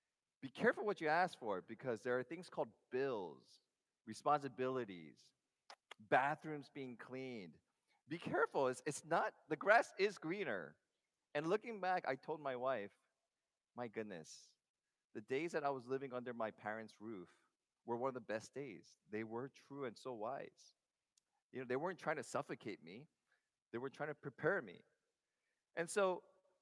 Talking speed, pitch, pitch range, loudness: 160 wpm, 140 Hz, 125-170 Hz, -43 LUFS